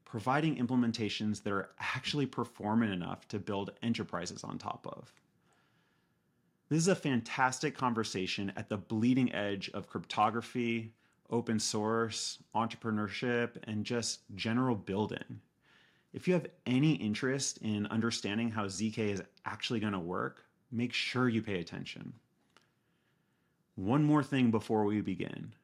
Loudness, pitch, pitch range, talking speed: -34 LUFS, 115 Hz, 105-125 Hz, 130 wpm